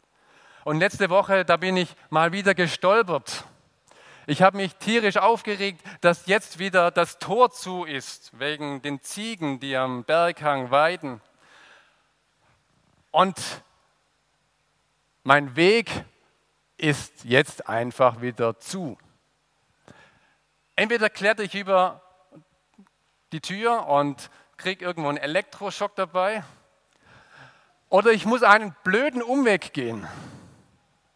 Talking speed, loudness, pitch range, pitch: 105 wpm, -23 LUFS, 145-200 Hz, 180 Hz